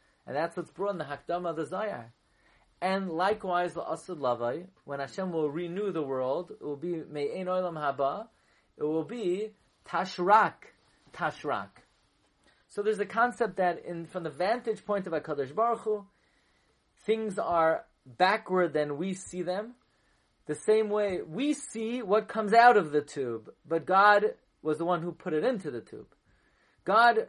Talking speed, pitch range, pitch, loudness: 165 wpm, 160-215 Hz, 180 Hz, -29 LUFS